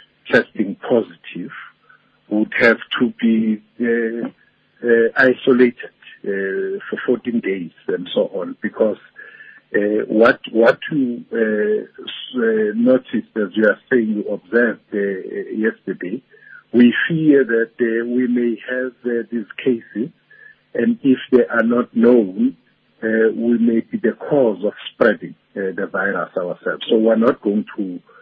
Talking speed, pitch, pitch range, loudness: 140 wpm, 120 Hz, 110-130 Hz, -18 LUFS